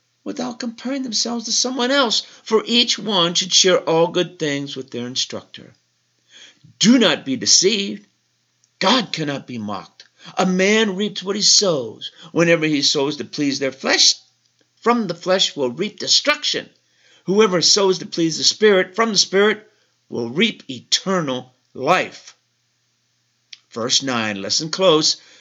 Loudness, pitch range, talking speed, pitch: -17 LUFS, 145-220 Hz, 145 wpm, 185 Hz